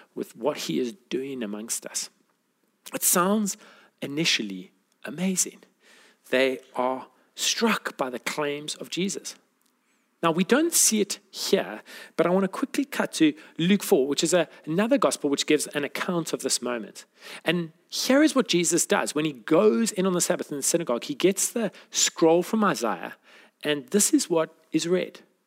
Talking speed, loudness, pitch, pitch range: 175 wpm, -25 LUFS, 175 Hz, 150-210 Hz